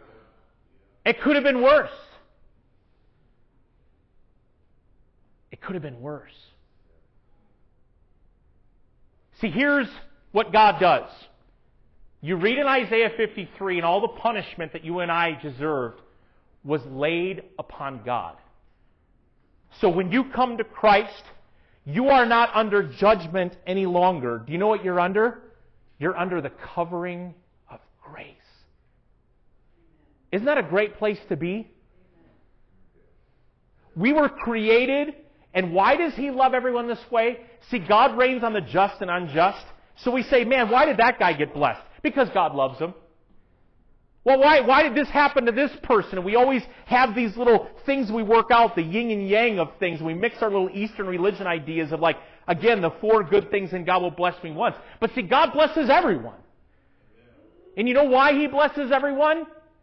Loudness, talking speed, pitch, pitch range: -22 LUFS, 155 wpm, 210 Hz, 175-250 Hz